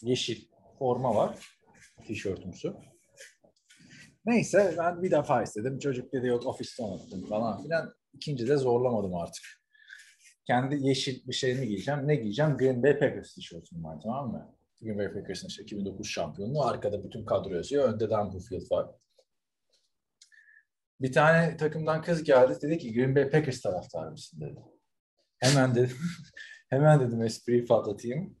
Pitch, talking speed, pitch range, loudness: 130 Hz, 140 wpm, 115-155 Hz, -29 LUFS